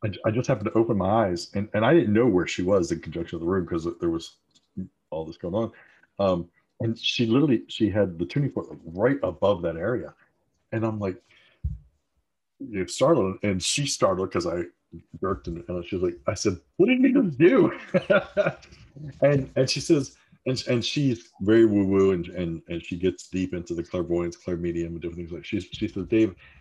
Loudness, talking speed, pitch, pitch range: -25 LUFS, 210 wpm, 100 Hz, 85-130 Hz